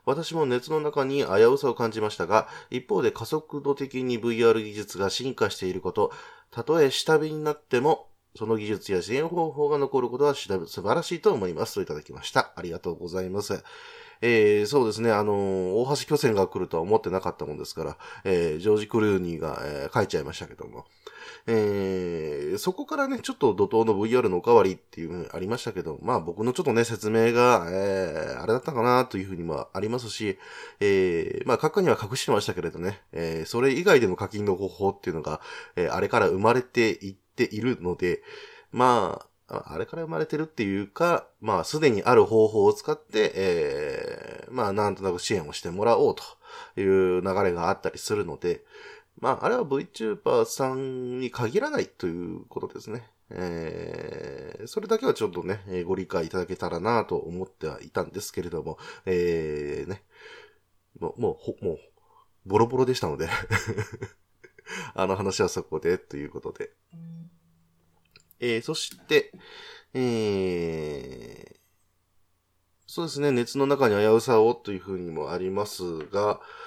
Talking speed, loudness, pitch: 355 characters per minute, -26 LUFS, 125 Hz